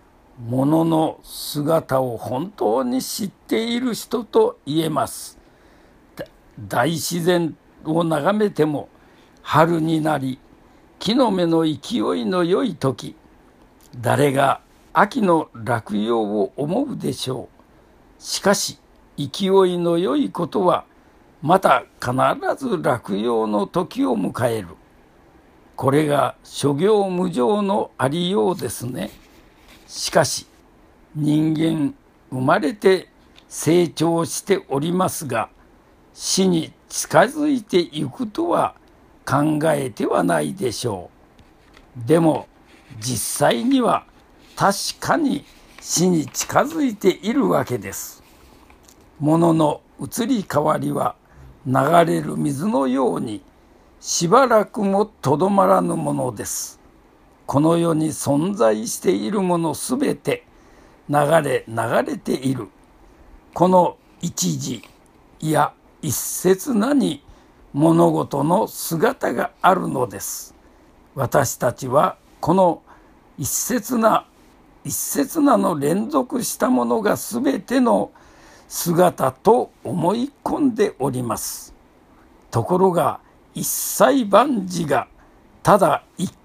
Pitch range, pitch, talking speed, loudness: 145-210 Hz, 170 Hz, 185 characters per minute, -20 LUFS